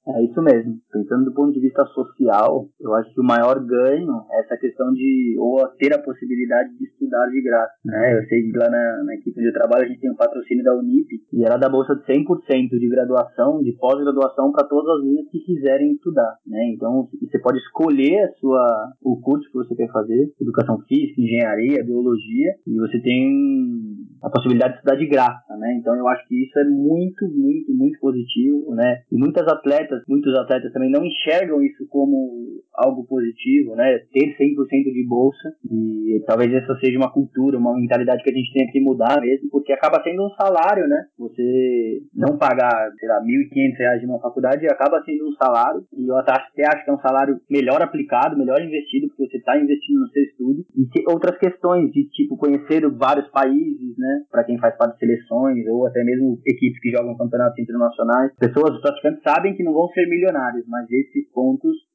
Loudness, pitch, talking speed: -19 LUFS, 140 Hz, 205 wpm